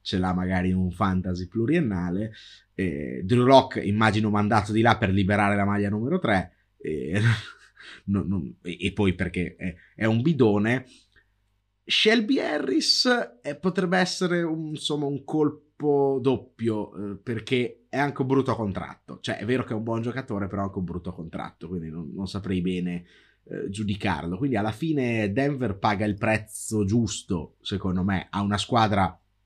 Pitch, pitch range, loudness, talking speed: 105 Hz, 95-125 Hz, -25 LUFS, 165 wpm